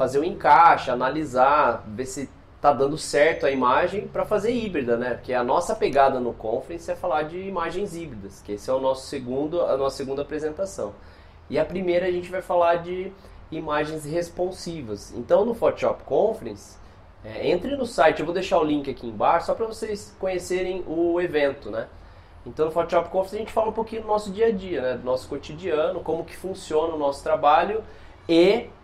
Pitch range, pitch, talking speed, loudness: 130-185 Hz, 155 Hz, 195 wpm, -24 LUFS